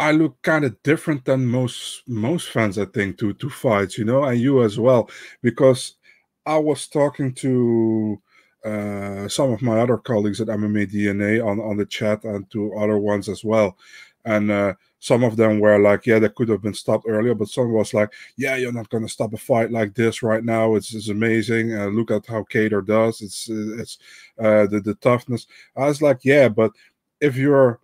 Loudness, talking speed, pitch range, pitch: -20 LUFS, 205 wpm, 105-125 Hz, 110 Hz